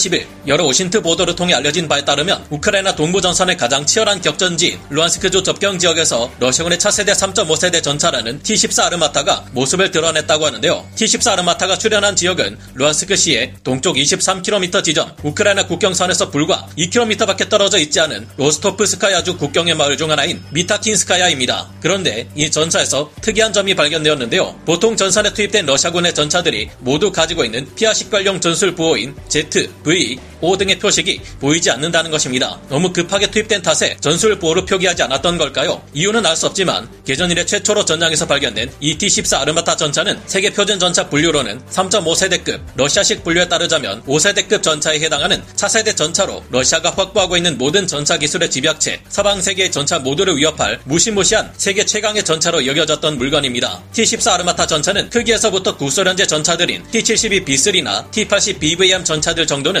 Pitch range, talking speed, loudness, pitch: 155-200 Hz, 415 characters per minute, -14 LUFS, 175 Hz